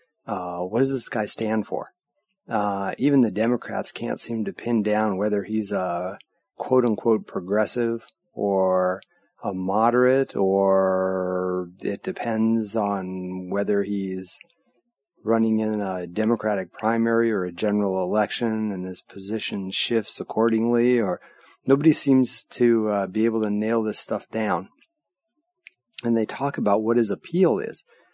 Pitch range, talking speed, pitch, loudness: 100-120 Hz, 135 wpm, 110 Hz, -24 LUFS